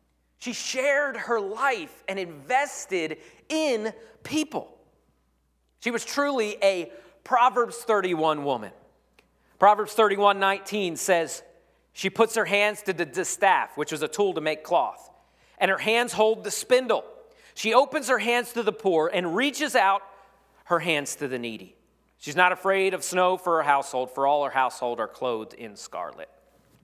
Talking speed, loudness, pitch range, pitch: 155 wpm, -25 LUFS, 160-235 Hz, 195 Hz